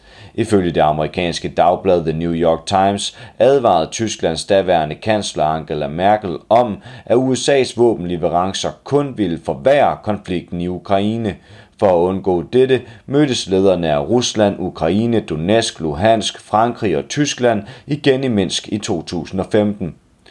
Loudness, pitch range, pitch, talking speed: -17 LUFS, 90-120 Hz, 105 Hz, 125 wpm